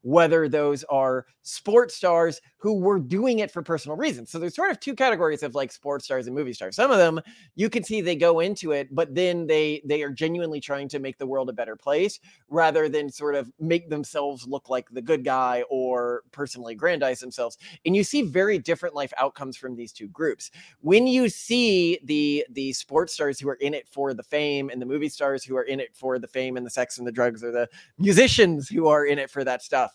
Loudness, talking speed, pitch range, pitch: -24 LUFS, 230 wpm, 130-170 Hz, 145 Hz